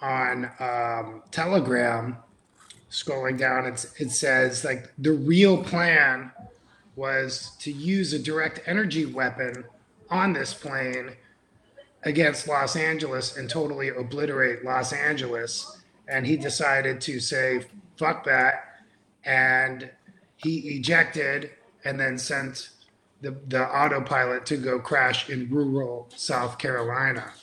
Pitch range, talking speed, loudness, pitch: 125-155 Hz, 115 wpm, -25 LUFS, 135 Hz